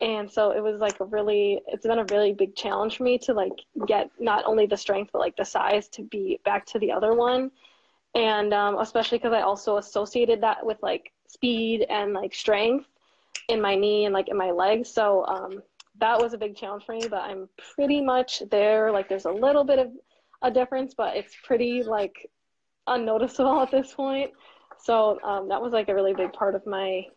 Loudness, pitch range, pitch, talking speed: -25 LUFS, 205-245 Hz, 220 Hz, 210 wpm